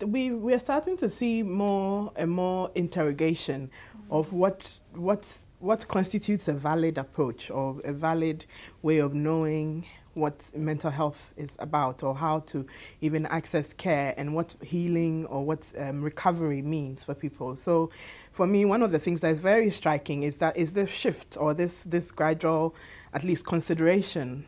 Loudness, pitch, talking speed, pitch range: -28 LUFS, 160 Hz, 165 wpm, 145-180 Hz